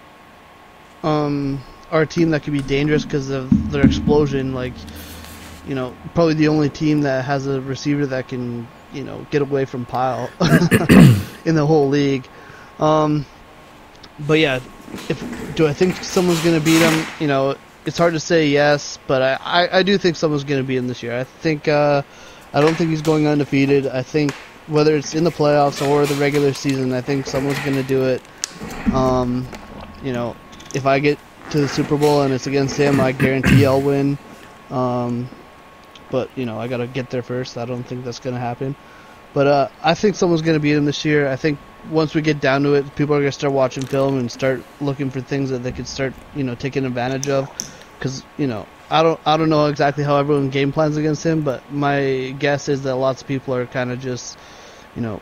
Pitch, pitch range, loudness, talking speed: 140 Hz, 130-150 Hz, -19 LUFS, 205 wpm